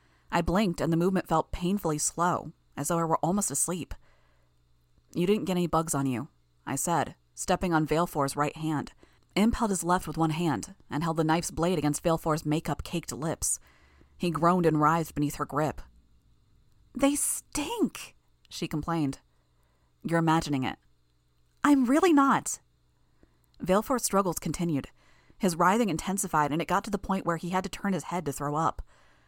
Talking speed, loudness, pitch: 170 wpm, -28 LUFS, 155 Hz